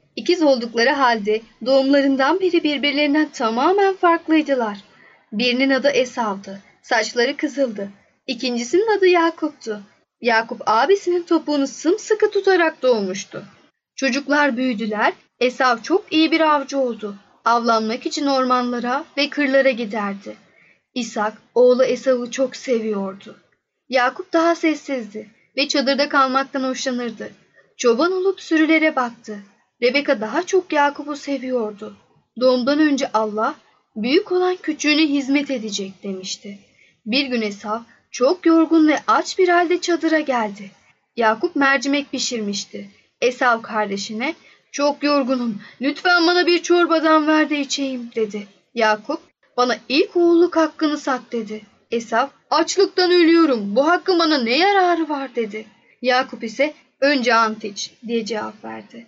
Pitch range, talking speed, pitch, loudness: 230-310 Hz, 120 wpm, 270 Hz, -19 LUFS